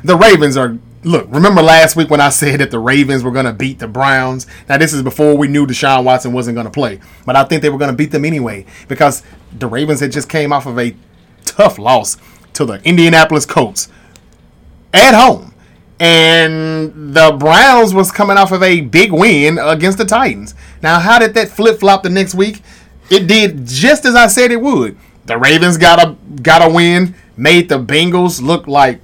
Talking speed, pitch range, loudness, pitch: 205 wpm, 135-180 Hz, -9 LUFS, 155 Hz